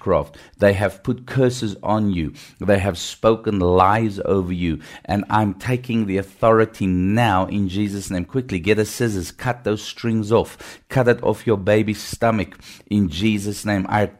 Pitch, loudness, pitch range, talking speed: 105 Hz, -20 LUFS, 95-110 Hz, 170 wpm